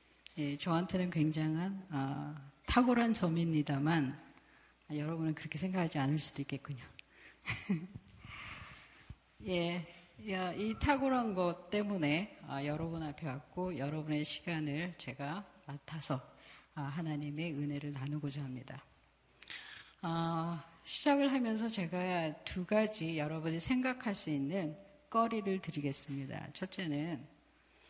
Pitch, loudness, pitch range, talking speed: 160 Hz, -37 LUFS, 145-185 Hz, 245 characters per minute